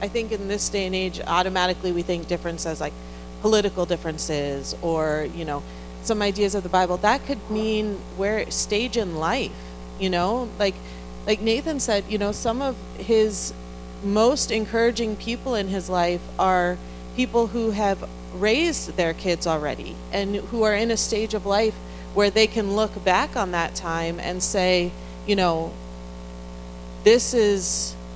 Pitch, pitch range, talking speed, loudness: 190 Hz, 160-215 Hz, 160 wpm, -23 LUFS